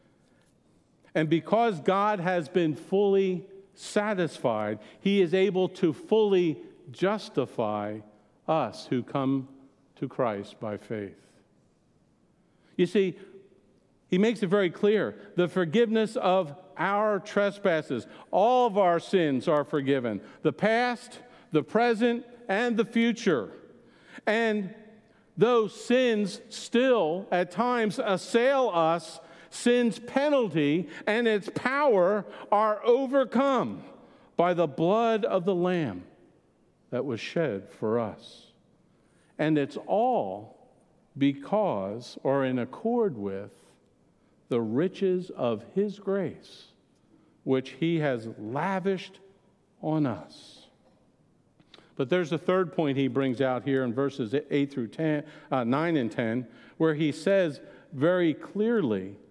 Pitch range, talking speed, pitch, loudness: 140-215 Hz, 115 wpm, 180 Hz, -27 LUFS